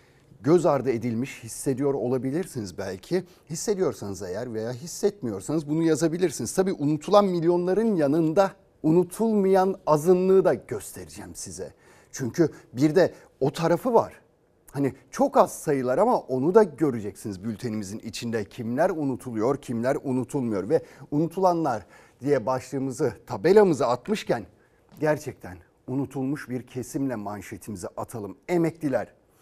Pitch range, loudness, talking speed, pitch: 120-170 Hz, -25 LUFS, 110 wpm, 140 Hz